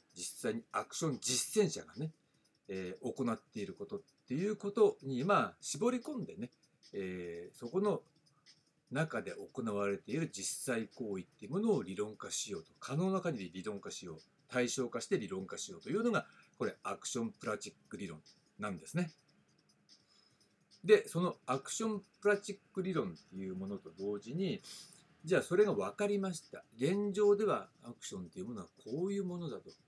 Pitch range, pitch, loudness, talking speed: 125-200 Hz, 170 Hz, -37 LUFS, 345 characters per minute